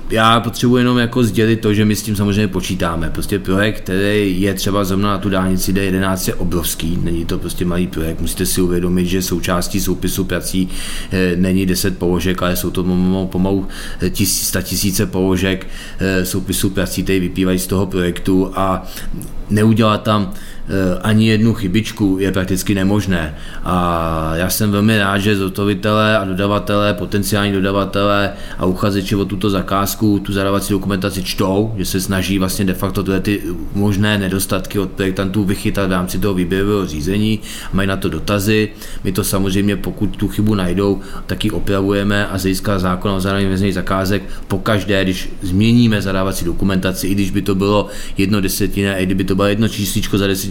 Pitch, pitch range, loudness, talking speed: 95 Hz, 95-100 Hz, -17 LUFS, 170 wpm